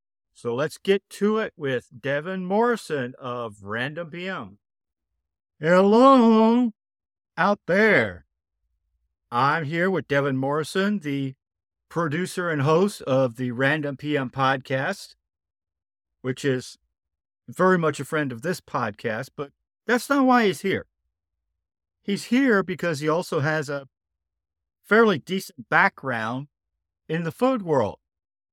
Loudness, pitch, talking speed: -23 LUFS, 140 Hz, 120 wpm